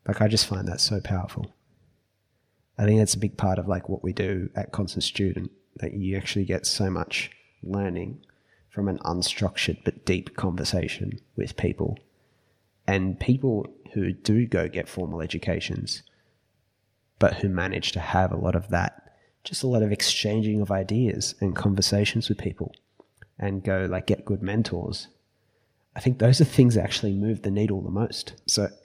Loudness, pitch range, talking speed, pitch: -26 LUFS, 95-110 Hz, 175 wpm, 100 Hz